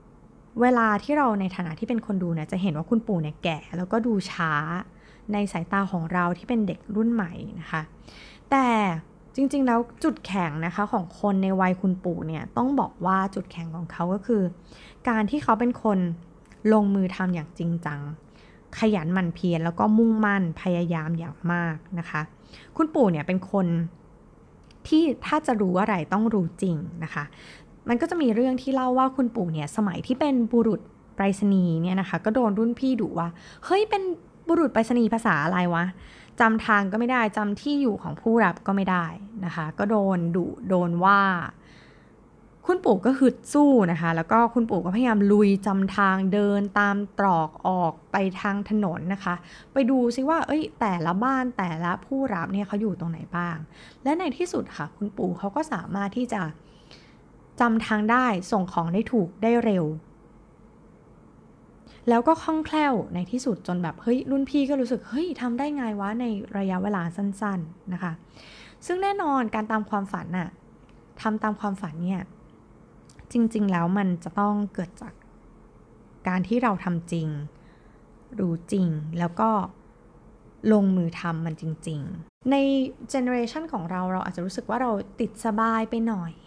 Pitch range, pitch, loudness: 175-235 Hz, 200 Hz, -25 LUFS